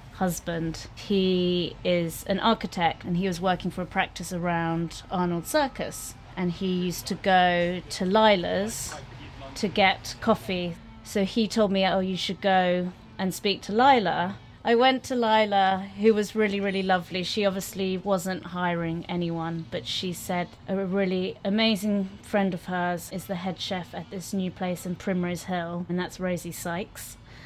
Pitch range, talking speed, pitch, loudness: 175-195 Hz, 165 wpm, 185 Hz, -26 LUFS